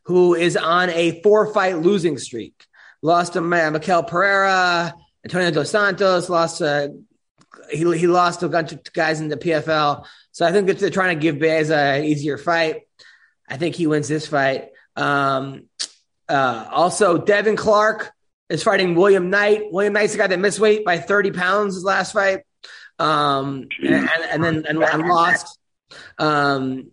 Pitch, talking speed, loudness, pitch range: 170 Hz, 170 wpm, -18 LUFS, 155-195 Hz